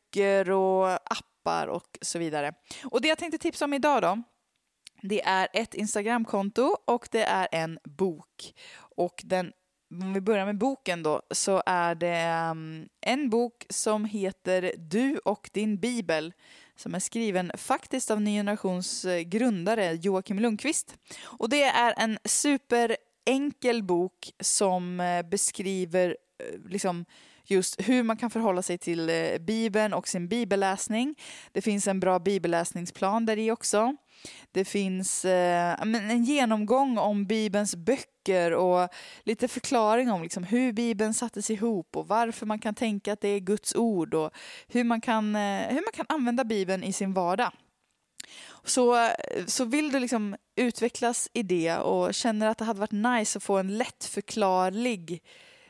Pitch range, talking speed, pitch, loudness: 185-235 Hz, 150 wpm, 210 Hz, -28 LUFS